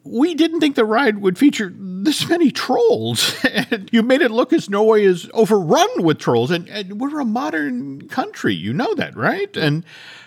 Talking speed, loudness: 185 wpm, -18 LUFS